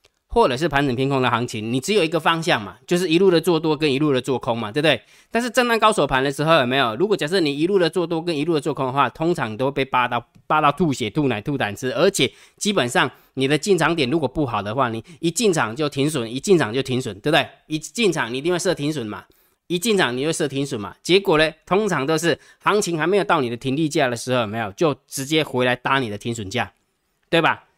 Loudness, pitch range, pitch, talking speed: -20 LUFS, 130-175 Hz, 150 Hz, 370 characters per minute